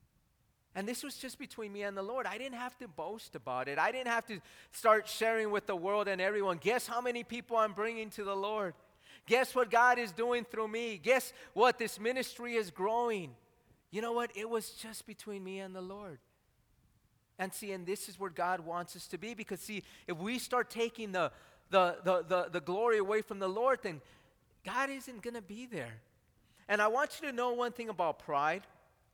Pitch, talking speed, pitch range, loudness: 215 Hz, 215 wpm, 185-235 Hz, -35 LUFS